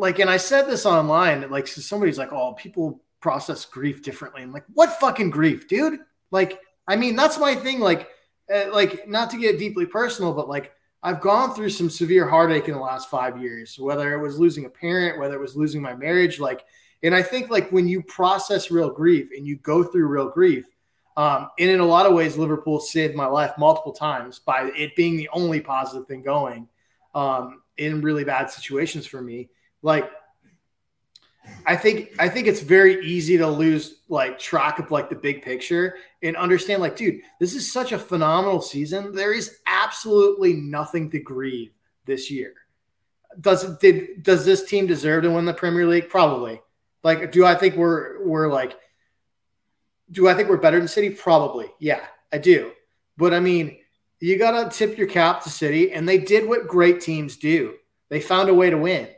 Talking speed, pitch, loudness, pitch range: 195 wpm, 170 Hz, -21 LUFS, 150-195 Hz